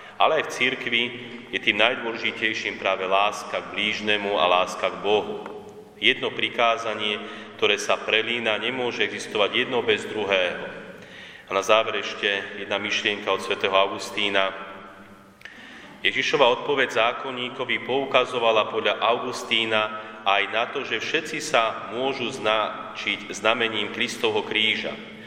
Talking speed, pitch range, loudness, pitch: 120 wpm, 95-120 Hz, -23 LUFS, 110 Hz